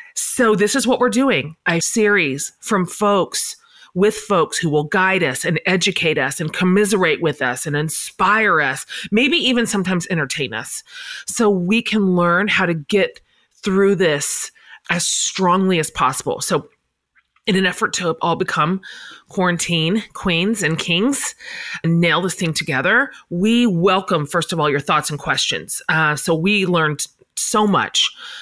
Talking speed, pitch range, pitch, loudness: 160 wpm, 165-210 Hz, 185 Hz, -18 LUFS